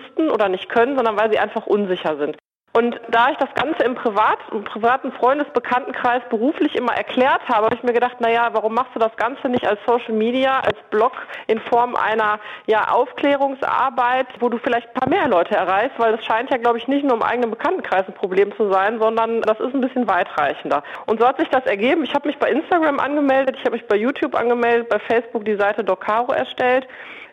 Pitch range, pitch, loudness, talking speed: 220-260 Hz, 240 Hz, -19 LUFS, 215 wpm